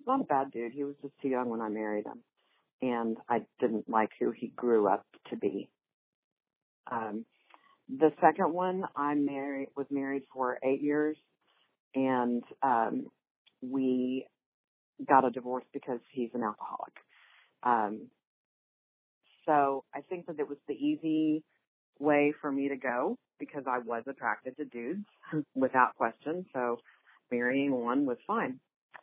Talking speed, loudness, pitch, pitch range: 145 wpm, -32 LUFS, 140 Hz, 125-150 Hz